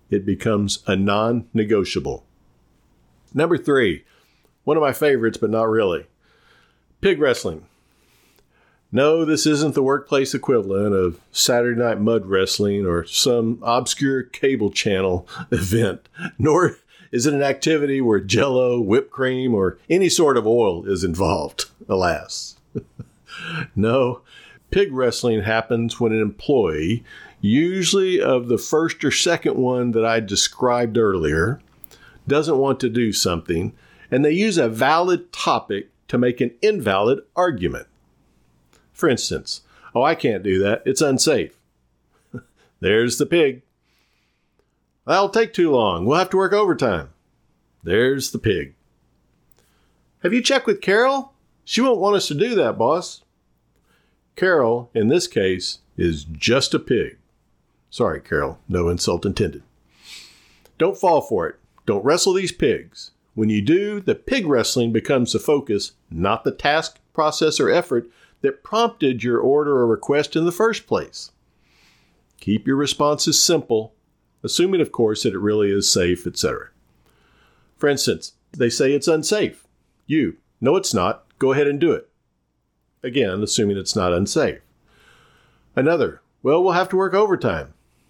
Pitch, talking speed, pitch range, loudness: 120 Hz, 140 wpm, 100-155 Hz, -20 LUFS